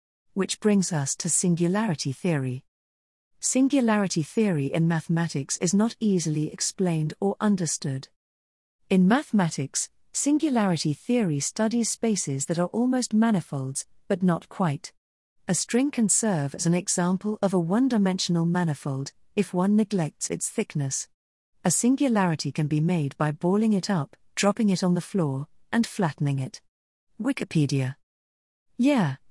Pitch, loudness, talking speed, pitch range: 175 Hz, -25 LUFS, 135 wpm, 145-205 Hz